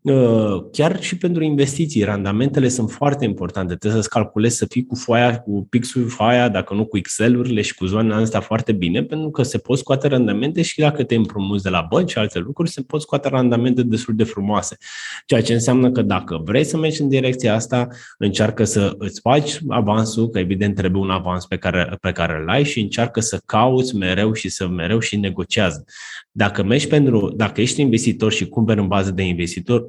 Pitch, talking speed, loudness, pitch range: 110 Hz, 200 wpm, -19 LUFS, 100-125 Hz